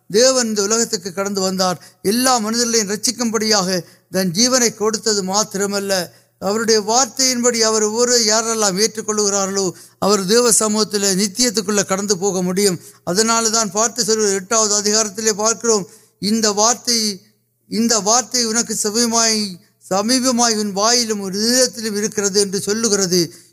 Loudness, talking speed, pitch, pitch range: -16 LUFS, 65 wpm, 215 Hz, 200-230 Hz